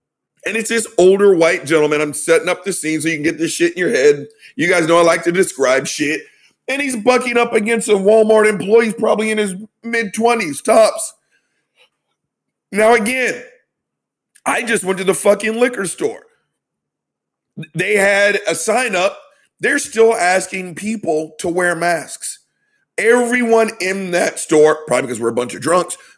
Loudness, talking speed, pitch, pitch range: -15 LUFS, 170 wpm, 205 Hz, 170-230 Hz